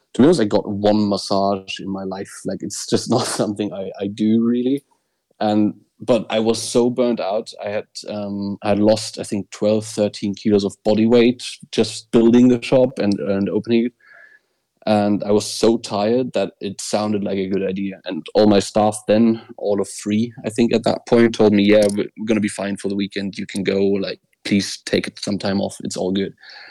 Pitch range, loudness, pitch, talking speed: 100-115 Hz, -19 LUFS, 105 Hz, 215 wpm